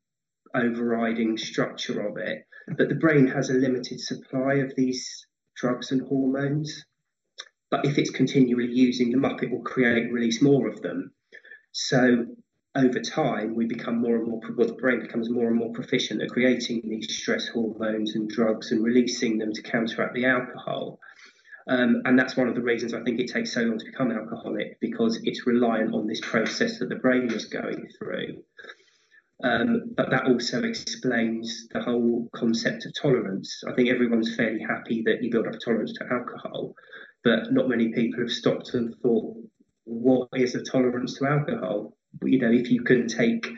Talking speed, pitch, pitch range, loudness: 180 wpm, 125 Hz, 115-130 Hz, -25 LUFS